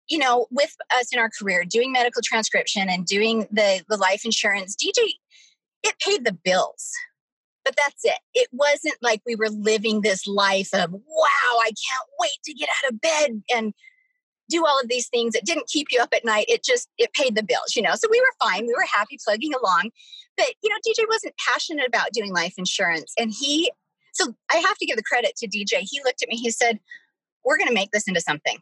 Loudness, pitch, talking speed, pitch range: -22 LUFS, 240 Hz, 220 wpm, 215-315 Hz